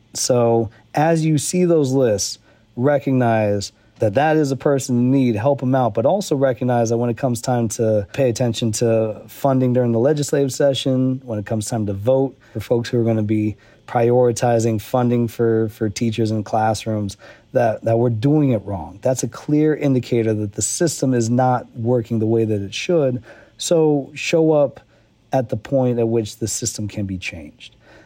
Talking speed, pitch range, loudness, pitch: 190 wpm, 110-135 Hz, -19 LUFS, 120 Hz